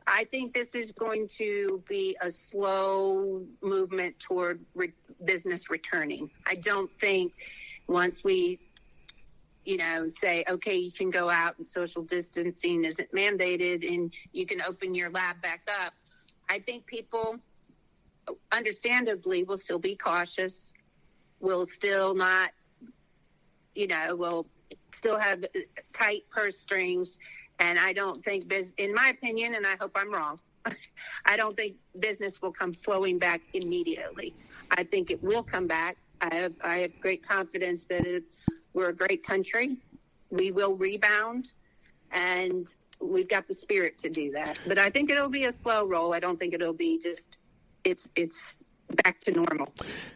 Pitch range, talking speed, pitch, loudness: 180-225 Hz, 155 wpm, 190 Hz, -29 LUFS